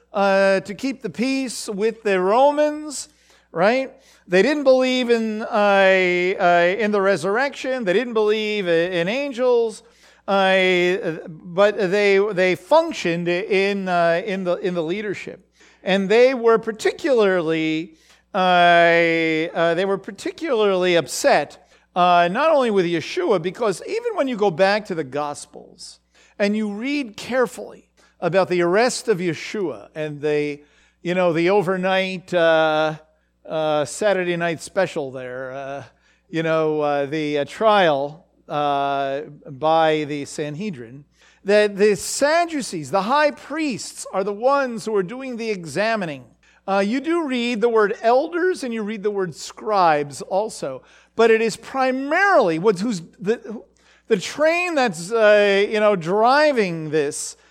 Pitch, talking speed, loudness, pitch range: 195 Hz, 140 wpm, -20 LUFS, 170-230 Hz